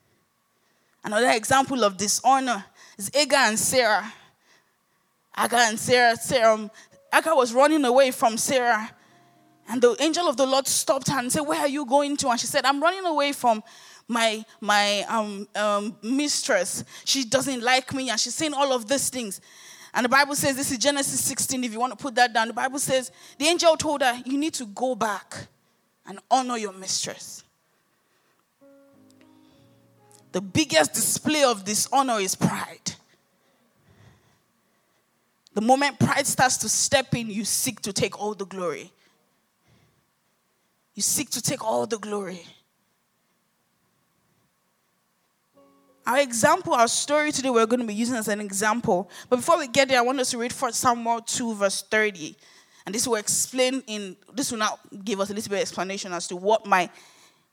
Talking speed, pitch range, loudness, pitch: 170 wpm, 210-275 Hz, -23 LUFS, 245 Hz